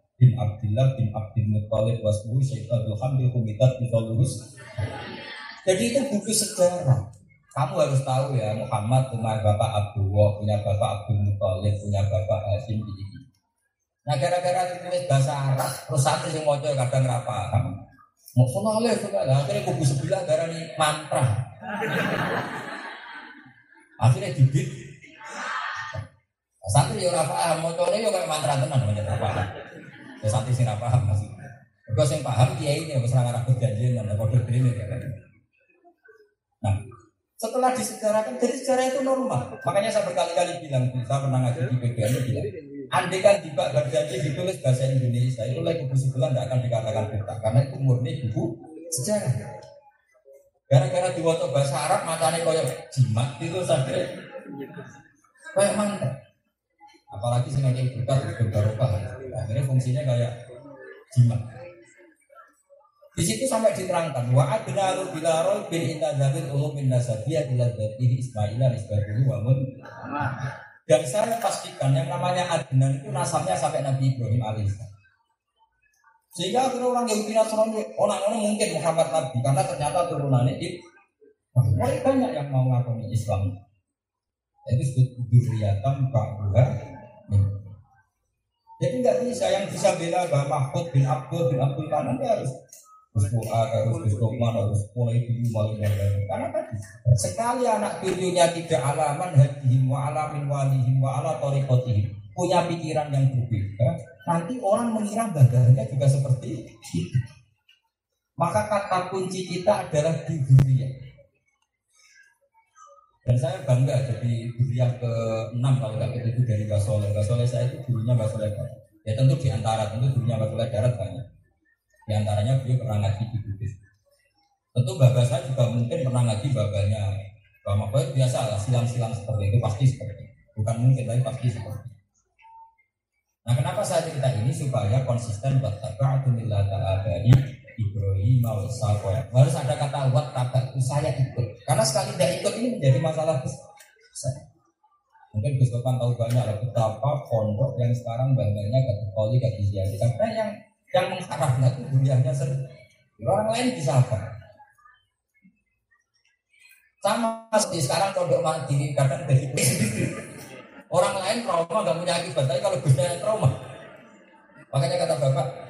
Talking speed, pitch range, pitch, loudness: 140 wpm, 115-160 Hz, 130 Hz, -24 LUFS